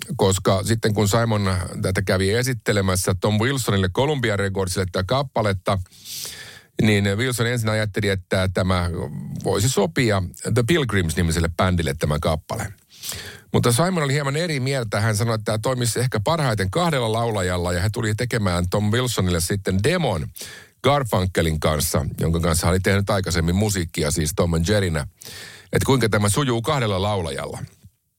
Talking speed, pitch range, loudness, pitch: 145 wpm, 95-120 Hz, -21 LUFS, 105 Hz